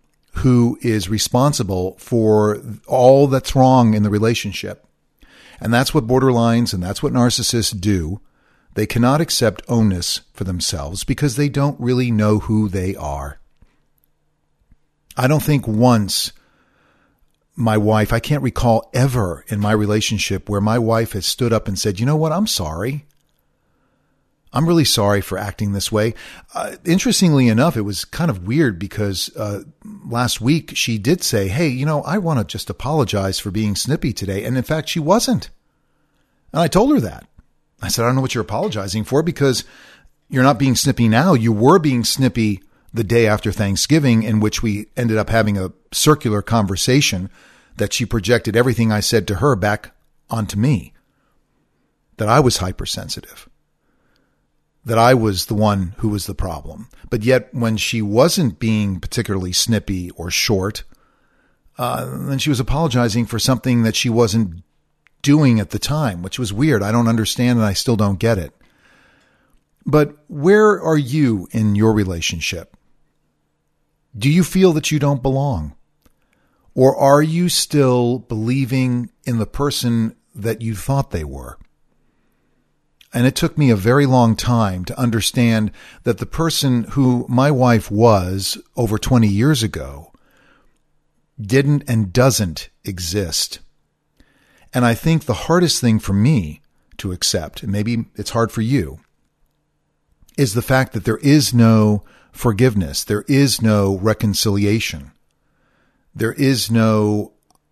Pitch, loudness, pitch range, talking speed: 115 Hz, -17 LUFS, 105-130 Hz, 155 wpm